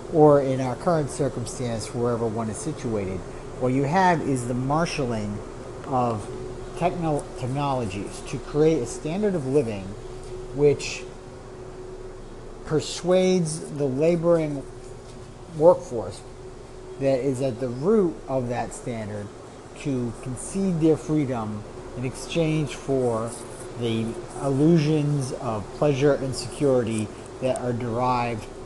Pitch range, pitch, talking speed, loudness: 120-150 Hz, 125 Hz, 110 wpm, -25 LUFS